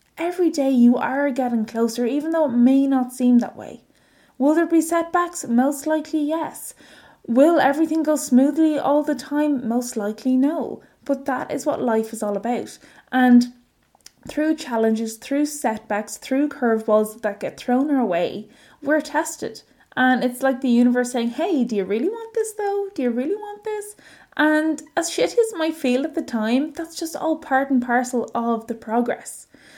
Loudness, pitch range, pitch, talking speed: -21 LUFS, 240-315 Hz, 270 Hz, 180 wpm